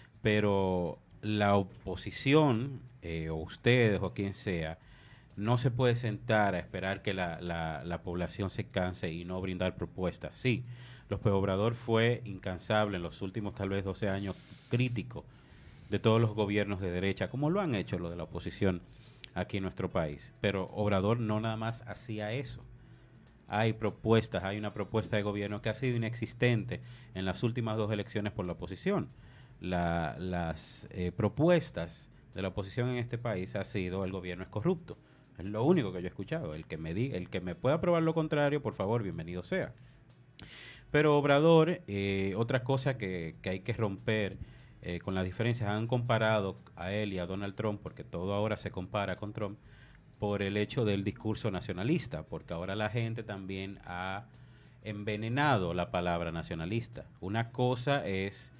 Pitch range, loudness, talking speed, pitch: 95-120 Hz, -33 LUFS, 175 wpm, 105 Hz